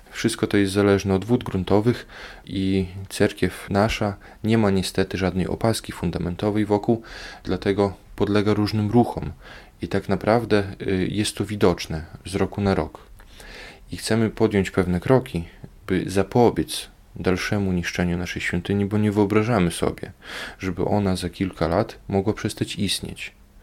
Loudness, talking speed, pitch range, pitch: -23 LUFS, 135 wpm, 95-105 Hz, 100 Hz